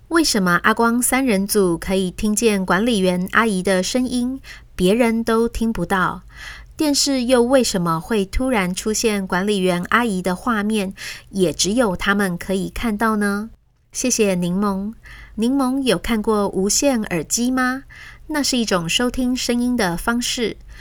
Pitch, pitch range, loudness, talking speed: 215 Hz, 190-245 Hz, -19 LUFS, 230 characters per minute